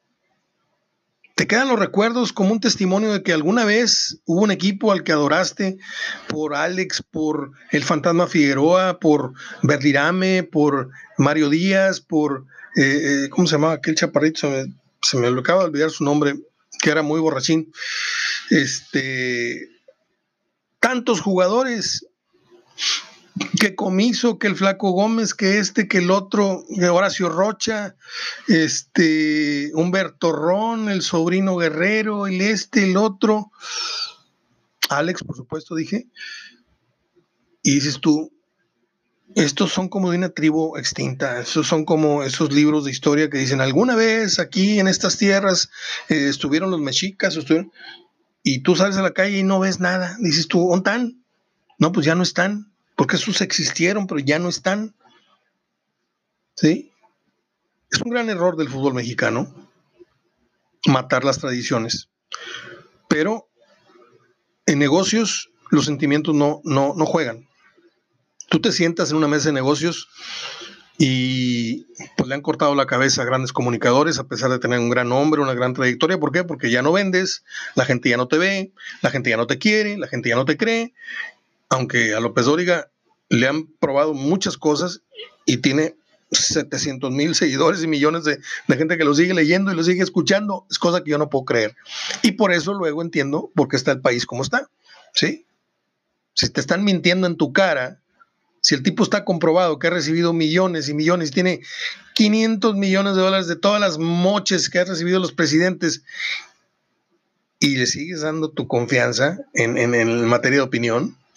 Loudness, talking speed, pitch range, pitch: -19 LUFS, 160 wpm, 150-195 Hz, 170 Hz